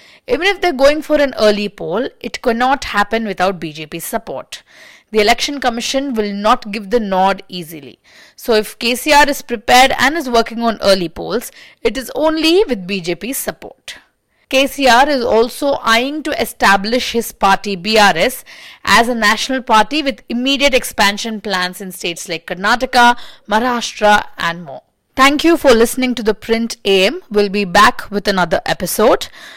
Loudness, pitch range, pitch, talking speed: -14 LUFS, 200-265 Hz, 230 Hz, 160 wpm